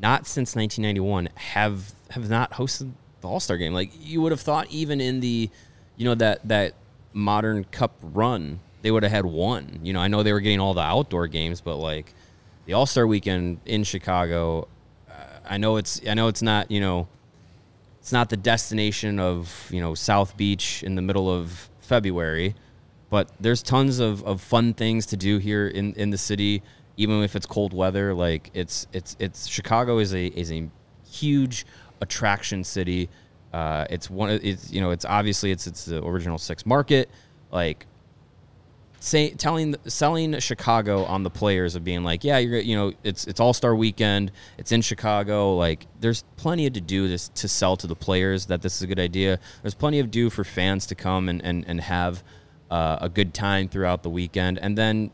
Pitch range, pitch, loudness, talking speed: 90-115 Hz, 100 Hz, -24 LUFS, 195 wpm